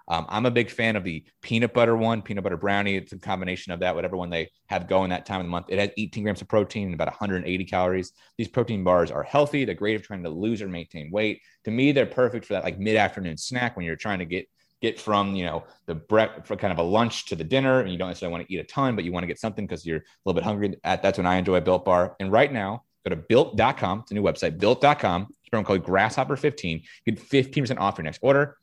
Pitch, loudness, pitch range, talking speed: 100 Hz, -25 LUFS, 90-115 Hz, 275 wpm